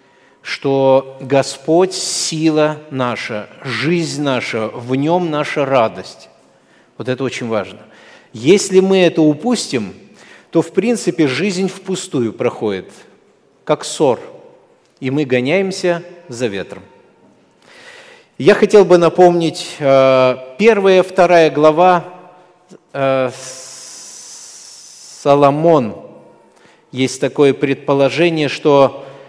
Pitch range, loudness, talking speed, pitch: 135-180 Hz, -14 LUFS, 90 wpm, 155 Hz